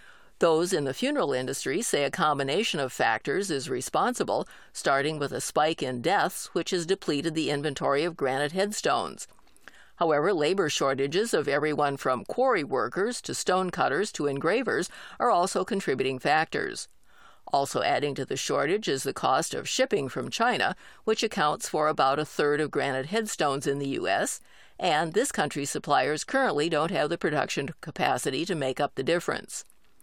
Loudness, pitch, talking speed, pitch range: -27 LUFS, 155 Hz, 165 wpm, 140-195 Hz